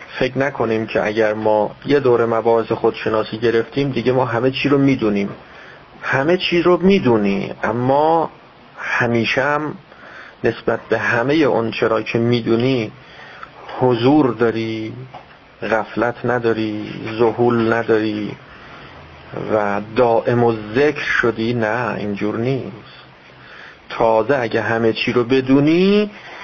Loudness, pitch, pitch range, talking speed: -17 LUFS, 115 Hz, 110-130 Hz, 115 wpm